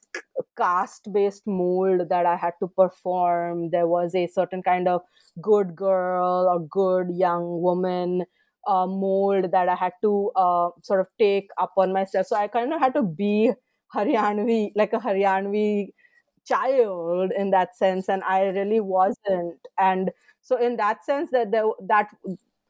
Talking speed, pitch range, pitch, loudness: 155 wpm, 180-210 Hz, 190 Hz, -23 LUFS